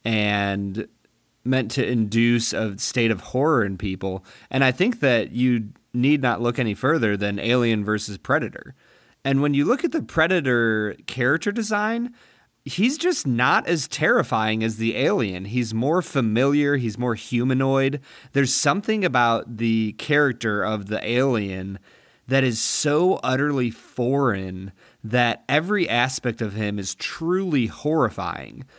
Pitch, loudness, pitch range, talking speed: 120 Hz, -22 LUFS, 110-145 Hz, 140 wpm